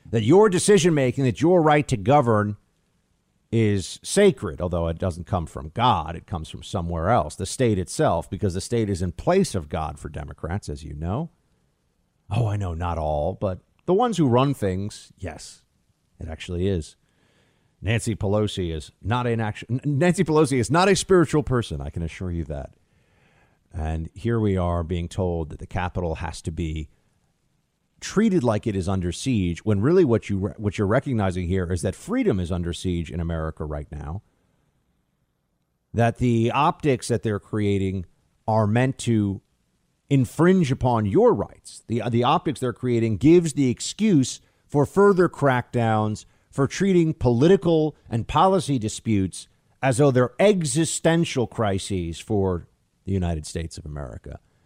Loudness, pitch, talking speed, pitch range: -23 LUFS, 105 Hz, 160 wpm, 90-130 Hz